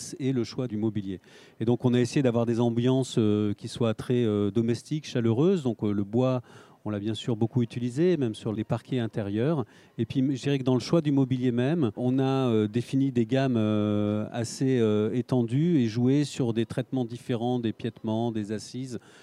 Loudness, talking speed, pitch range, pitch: -27 LUFS, 185 wpm, 110-130 Hz, 120 Hz